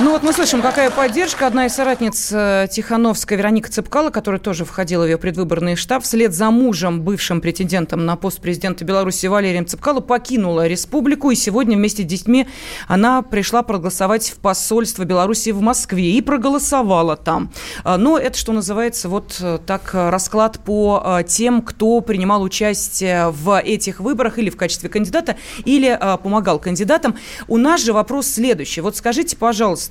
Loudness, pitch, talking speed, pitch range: -17 LUFS, 210 Hz, 155 wpm, 185-245 Hz